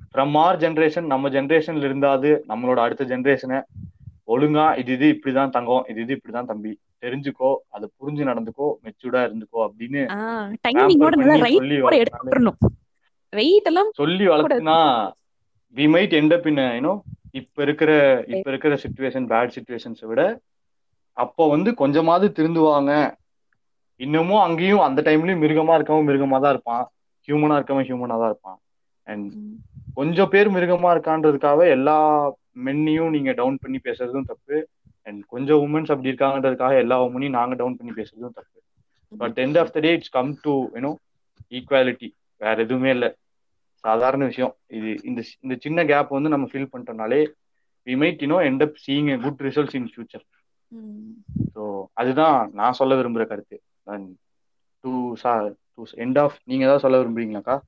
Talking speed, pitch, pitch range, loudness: 130 wpm, 135 Hz, 125-155 Hz, -20 LUFS